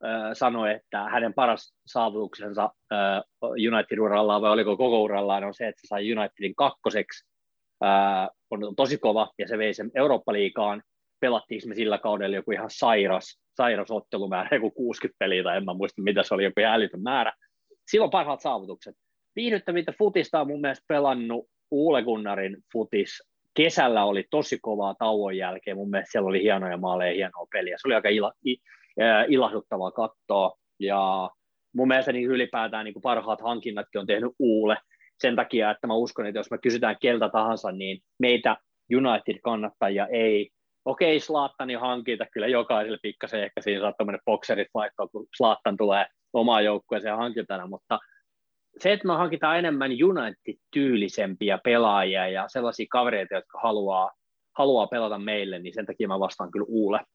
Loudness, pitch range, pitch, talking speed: -26 LUFS, 100-125 Hz, 110 Hz, 160 wpm